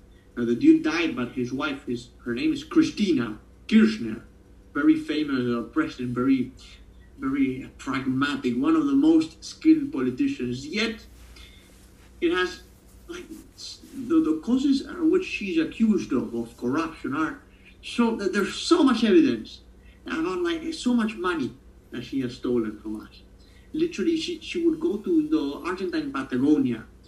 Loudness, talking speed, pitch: -25 LUFS, 150 wpm, 220 Hz